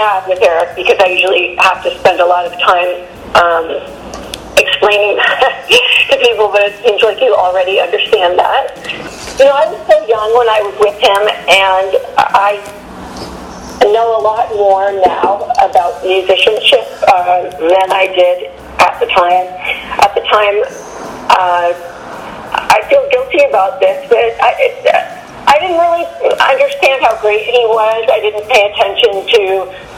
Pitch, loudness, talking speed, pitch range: 210 Hz, -10 LUFS, 155 wpm, 185-290 Hz